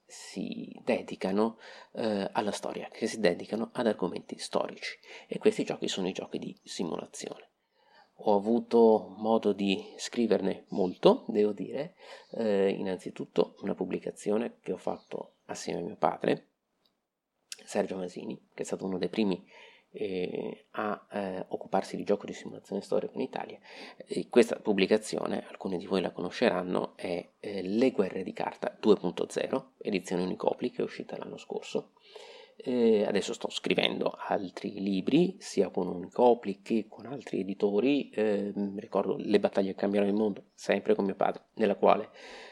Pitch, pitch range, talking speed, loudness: 105 Hz, 100-115 Hz, 150 wpm, -31 LUFS